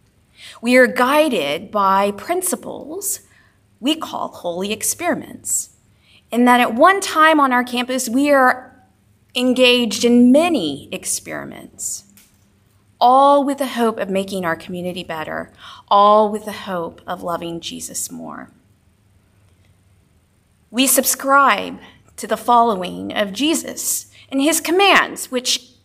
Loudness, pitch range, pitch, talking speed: -17 LUFS, 170-270 Hz, 240 Hz, 120 wpm